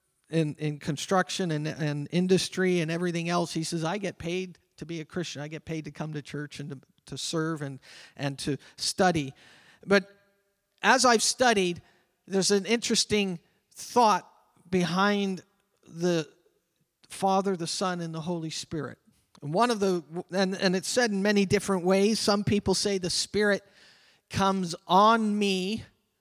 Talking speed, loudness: 160 wpm, -27 LUFS